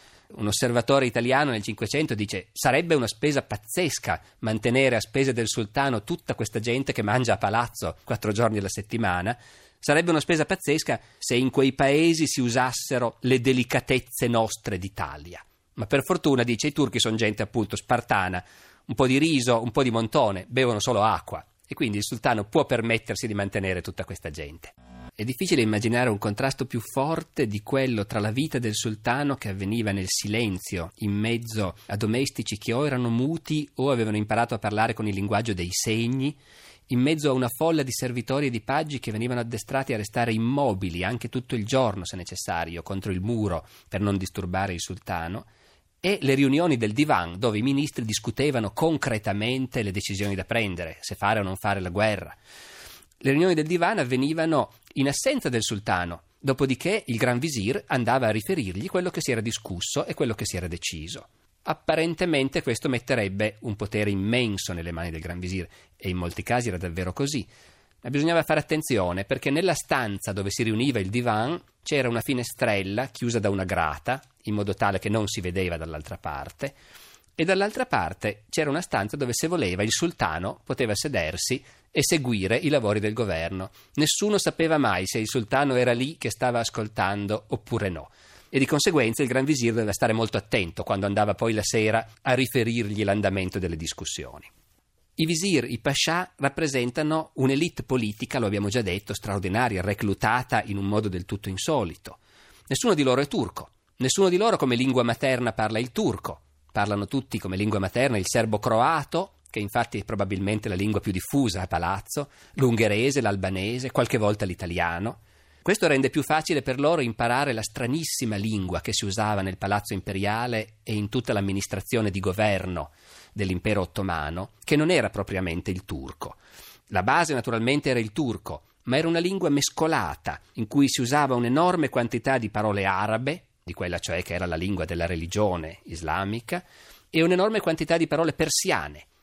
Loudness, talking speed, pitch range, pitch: -25 LUFS, 175 wpm, 100-135 Hz, 115 Hz